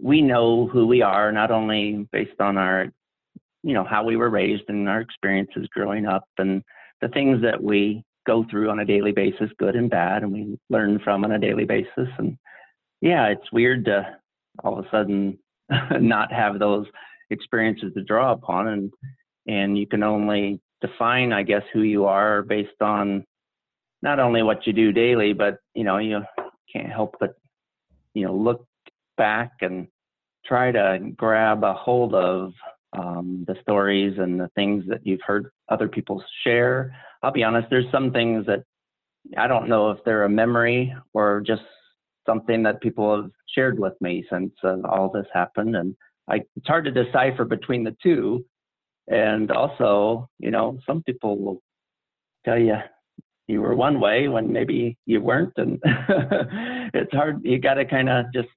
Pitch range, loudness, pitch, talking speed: 100-120 Hz, -22 LUFS, 110 Hz, 175 wpm